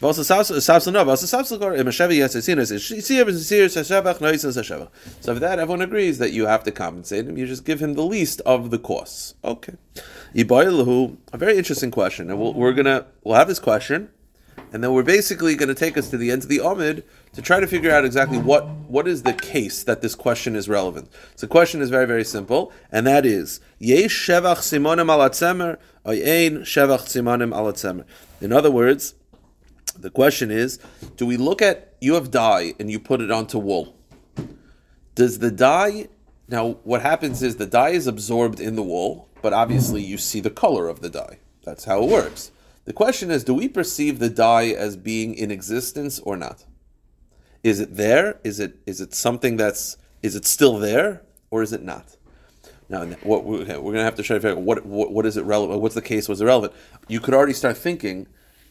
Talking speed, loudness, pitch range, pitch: 180 wpm, -20 LUFS, 110-155 Hz, 125 Hz